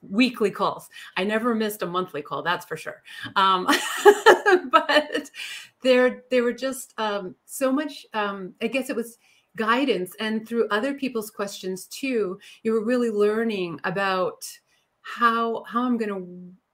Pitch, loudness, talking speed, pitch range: 225 Hz, -23 LUFS, 145 wpm, 195-255 Hz